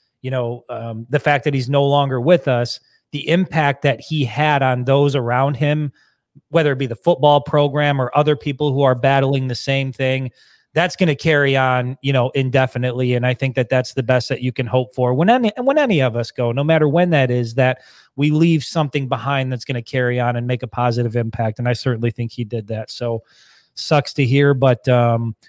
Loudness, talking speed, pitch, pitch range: -18 LUFS, 225 wpm, 135 Hz, 125-145 Hz